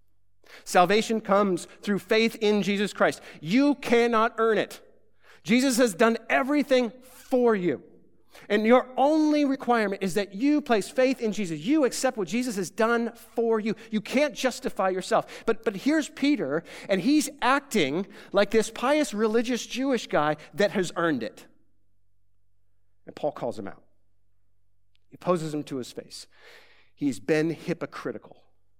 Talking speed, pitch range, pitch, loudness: 150 wpm, 170-250 Hz, 220 Hz, -25 LUFS